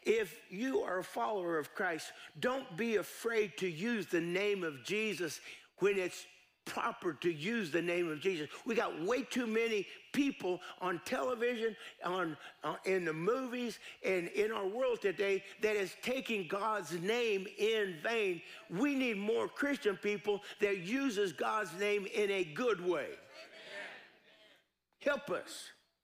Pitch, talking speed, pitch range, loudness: 205 Hz, 150 wpm, 185-240 Hz, -36 LUFS